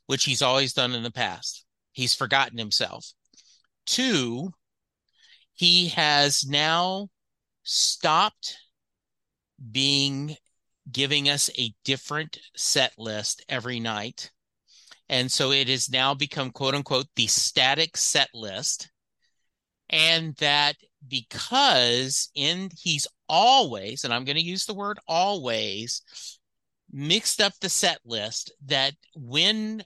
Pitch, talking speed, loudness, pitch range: 140 Hz, 115 wpm, -23 LUFS, 125-160 Hz